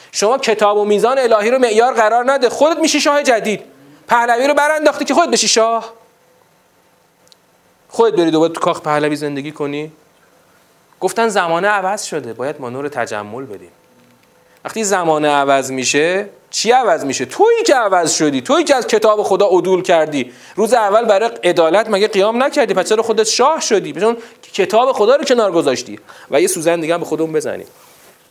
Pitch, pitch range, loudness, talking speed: 210 Hz, 160-235 Hz, -14 LUFS, 170 wpm